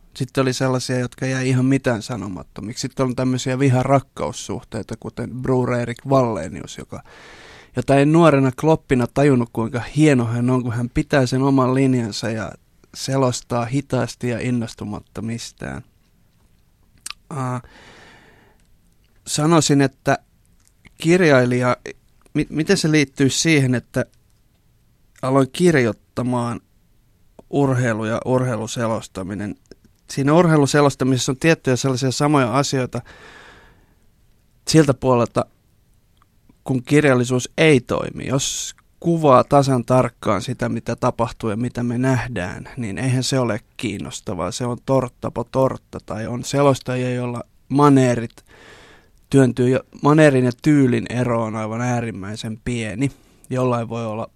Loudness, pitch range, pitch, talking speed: -19 LUFS, 115-135 Hz, 125 Hz, 105 wpm